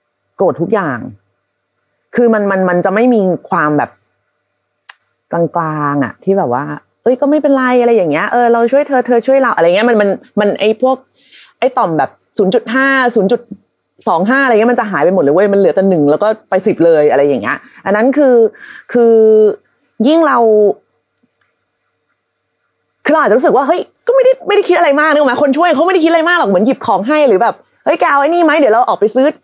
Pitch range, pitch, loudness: 195-280 Hz, 235 Hz, -11 LUFS